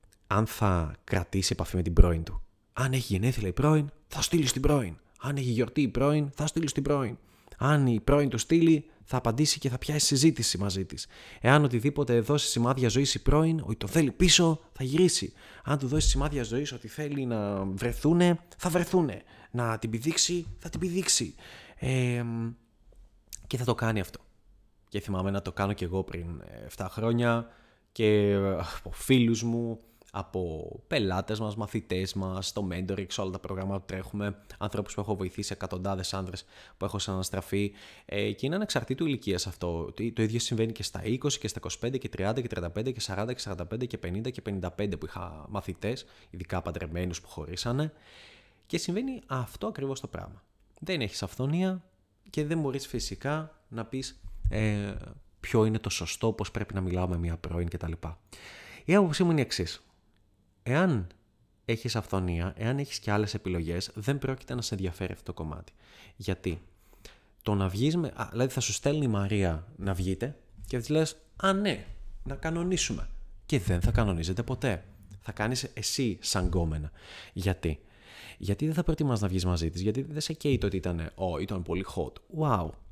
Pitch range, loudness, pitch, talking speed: 95-130 Hz, -30 LUFS, 110 Hz, 175 wpm